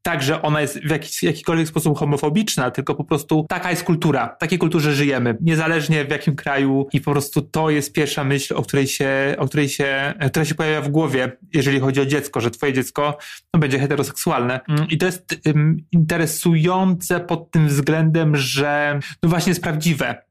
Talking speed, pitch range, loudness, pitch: 190 wpm, 140-165 Hz, -19 LUFS, 150 Hz